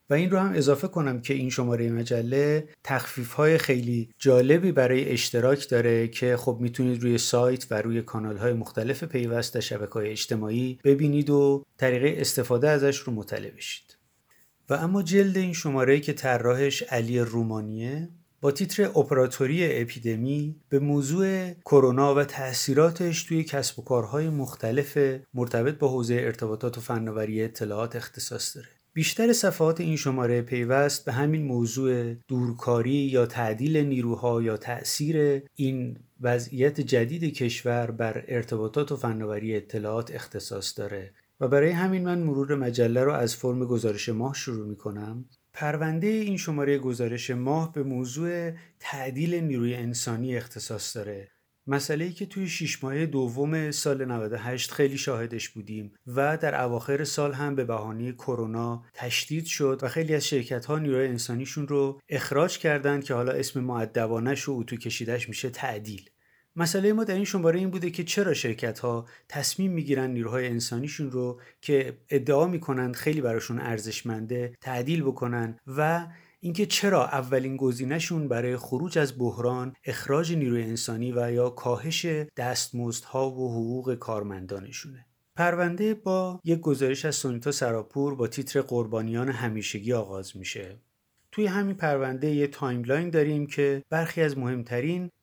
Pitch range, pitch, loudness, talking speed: 120-150 Hz, 130 Hz, -27 LUFS, 145 wpm